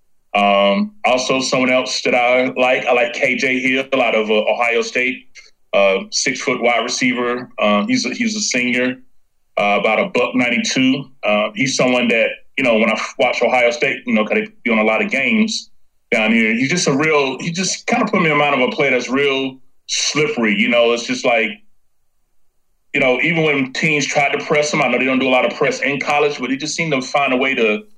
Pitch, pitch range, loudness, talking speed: 130 Hz, 120-150 Hz, -16 LUFS, 230 wpm